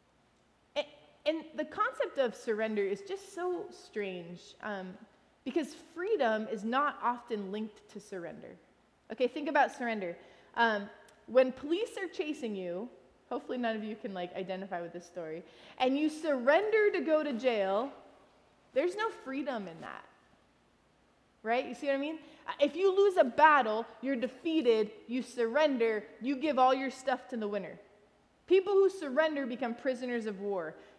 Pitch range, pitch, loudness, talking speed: 220-310 Hz, 255 Hz, -32 LUFS, 155 wpm